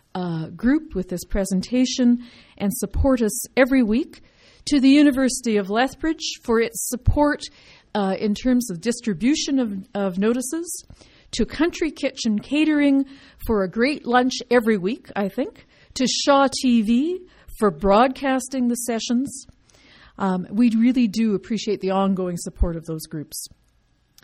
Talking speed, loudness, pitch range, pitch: 140 wpm, -21 LUFS, 200-265 Hz, 240 Hz